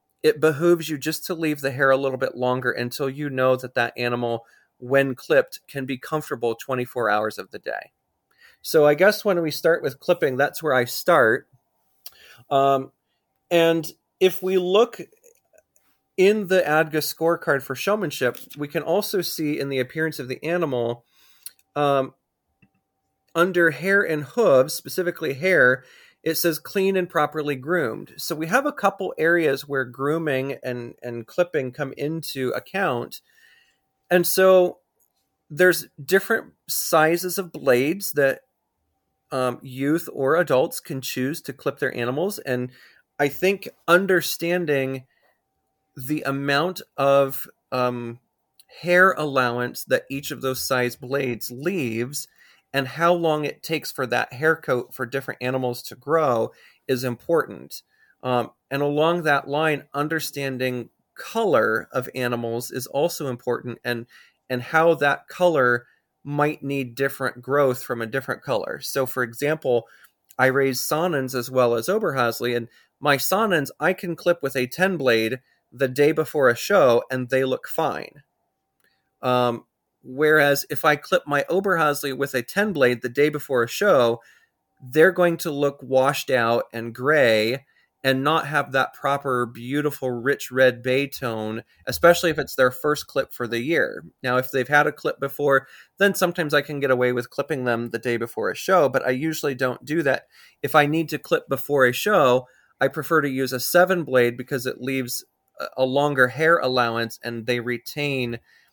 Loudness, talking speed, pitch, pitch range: -22 LUFS, 160 wpm, 140 Hz, 125-160 Hz